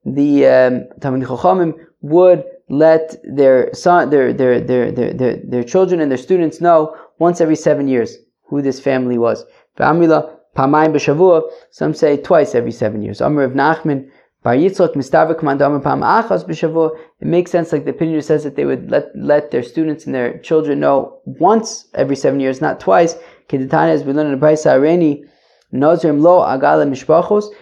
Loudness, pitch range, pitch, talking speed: -14 LUFS, 140-170 Hz, 155 Hz, 120 wpm